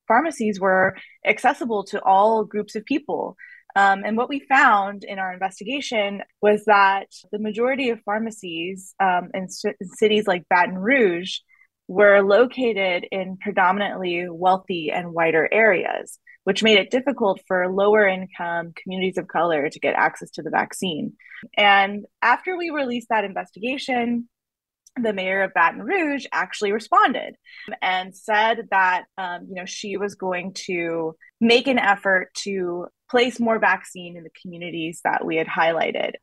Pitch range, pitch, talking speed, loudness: 185-225 Hz, 200 Hz, 150 wpm, -21 LUFS